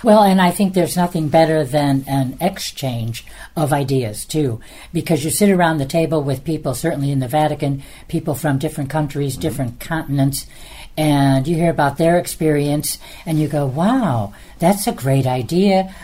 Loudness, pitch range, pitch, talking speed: -18 LUFS, 140-165 Hz, 155 Hz, 170 wpm